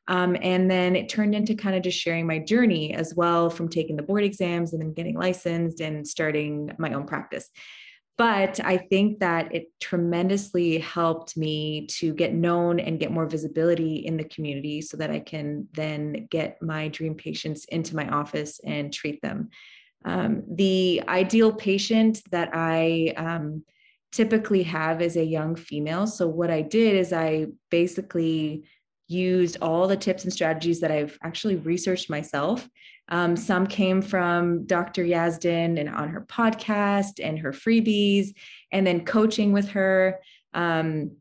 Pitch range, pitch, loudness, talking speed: 160-195 Hz, 170 Hz, -25 LUFS, 160 wpm